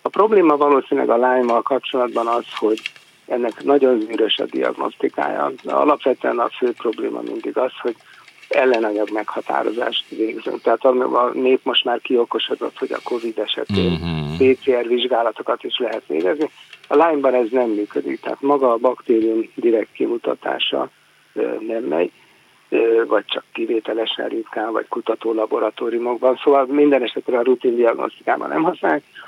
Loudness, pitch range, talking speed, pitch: -19 LUFS, 115-145 Hz, 135 wpm, 125 Hz